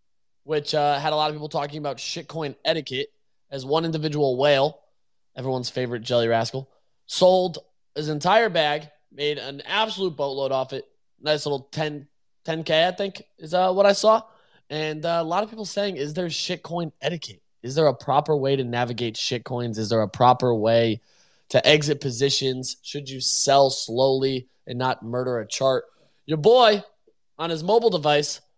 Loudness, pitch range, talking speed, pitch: -23 LUFS, 130-165 Hz, 170 wpm, 145 Hz